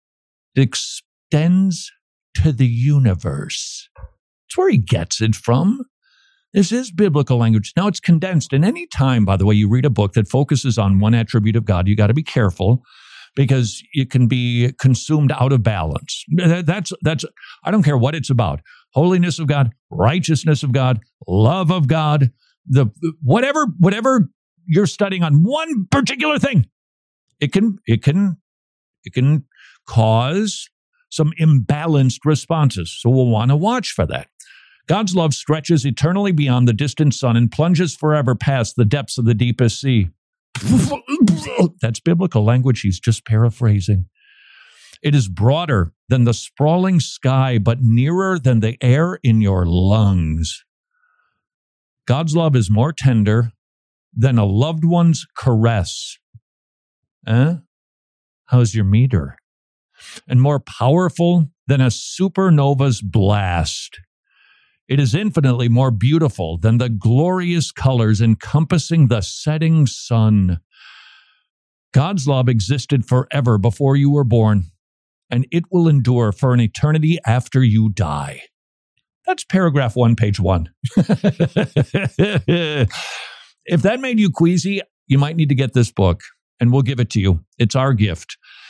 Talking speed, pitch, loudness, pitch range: 140 wpm, 135 Hz, -17 LUFS, 115-165 Hz